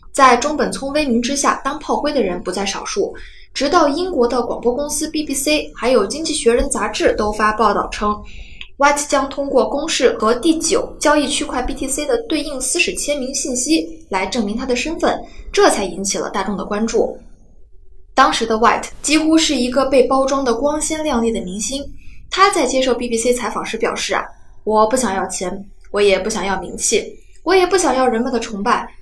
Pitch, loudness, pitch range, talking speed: 270 Hz, -17 LUFS, 225-305 Hz, 305 characters per minute